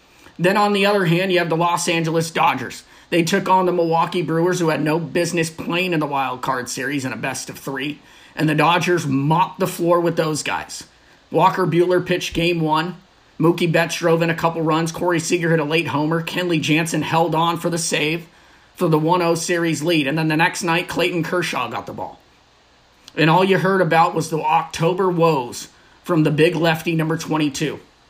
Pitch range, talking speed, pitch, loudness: 155-175 Hz, 205 wpm, 165 Hz, -19 LUFS